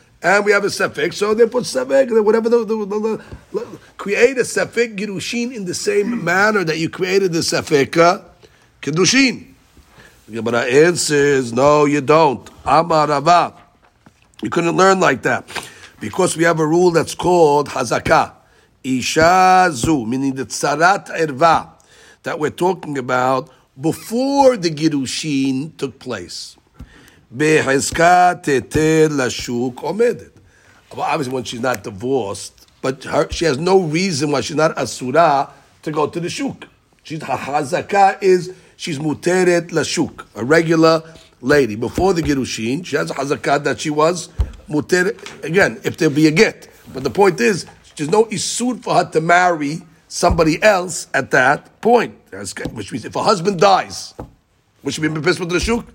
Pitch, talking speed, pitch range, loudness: 165 Hz, 150 wpm, 145-185 Hz, -16 LUFS